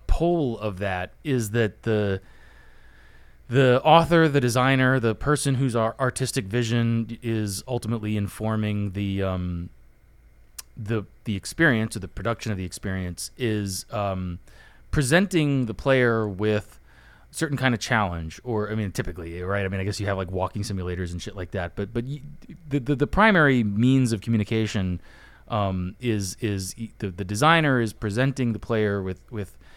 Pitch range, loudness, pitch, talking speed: 95-125 Hz, -24 LUFS, 110 Hz, 160 wpm